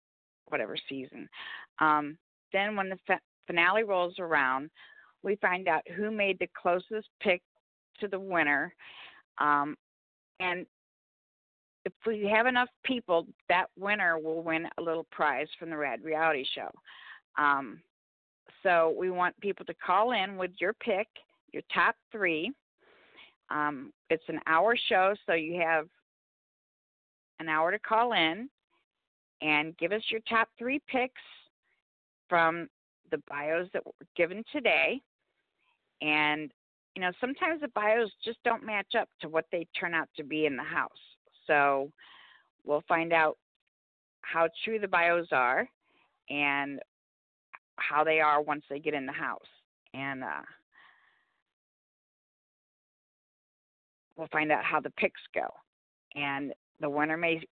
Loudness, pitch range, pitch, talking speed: -30 LUFS, 150-200 Hz, 165 Hz, 140 wpm